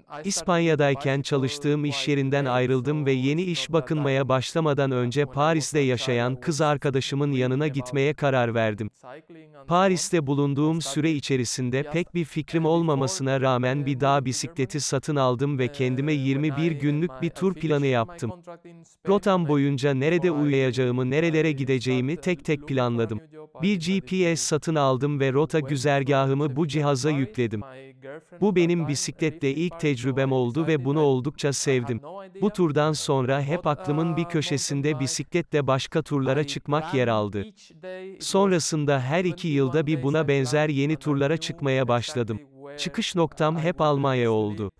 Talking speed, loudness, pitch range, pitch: 135 wpm, -24 LUFS, 135-160 Hz, 145 Hz